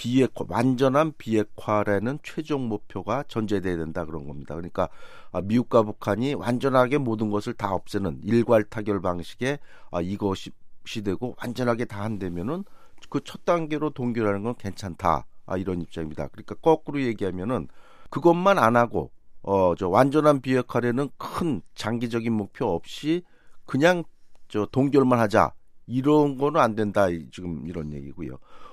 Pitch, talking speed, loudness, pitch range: 115 Hz, 310 characters per minute, -25 LUFS, 95-130 Hz